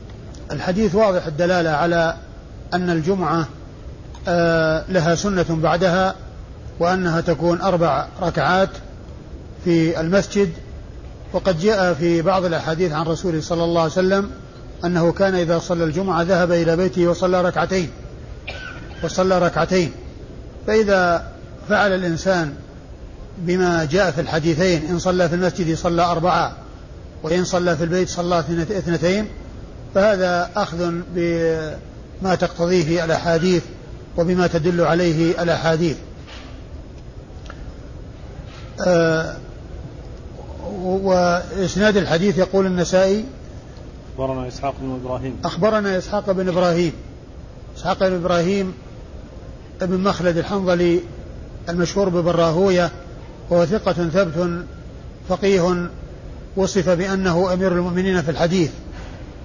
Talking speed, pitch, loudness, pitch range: 100 wpm, 175 Hz, -19 LUFS, 165-185 Hz